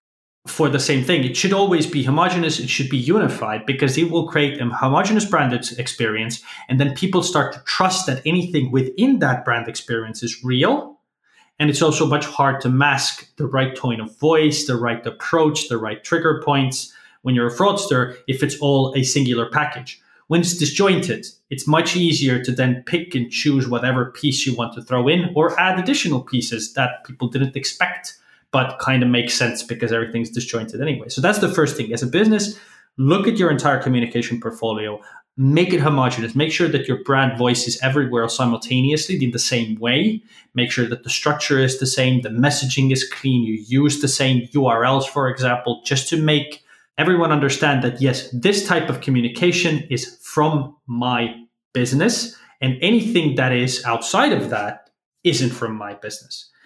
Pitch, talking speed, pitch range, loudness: 135 Hz, 185 wpm, 125-155 Hz, -19 LUFS